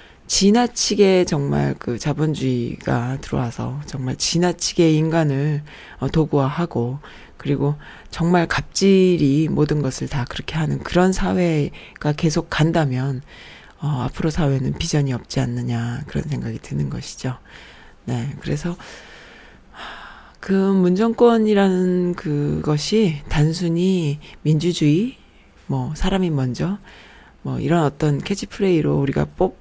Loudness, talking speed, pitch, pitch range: -20 LUFS, 255 characters per minute, 155 Hz, 135-180 Hz